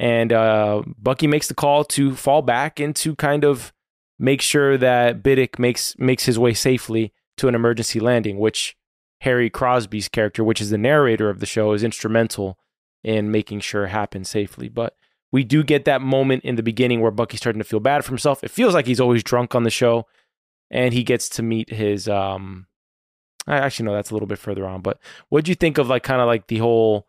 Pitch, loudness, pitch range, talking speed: 115 Hz, -20 LUFS, 105-130 Hz, 215 wpm